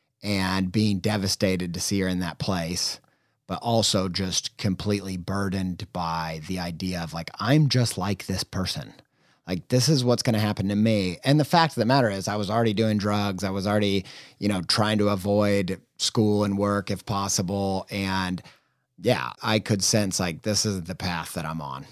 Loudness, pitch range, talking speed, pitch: -25 LUFS, 95-105 Hz, 190 wpm, 100 Hz